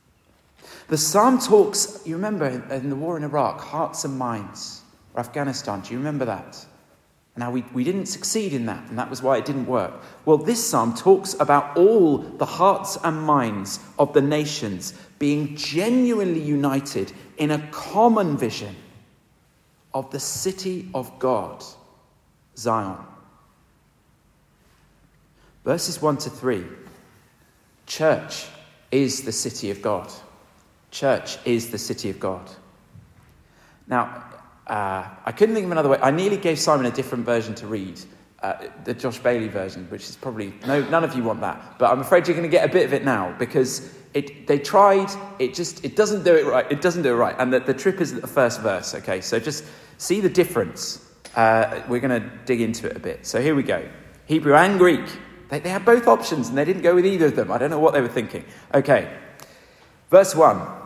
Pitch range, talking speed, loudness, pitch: 120-180 Hz, 185 wpm, -22 LUFS, 145 Hz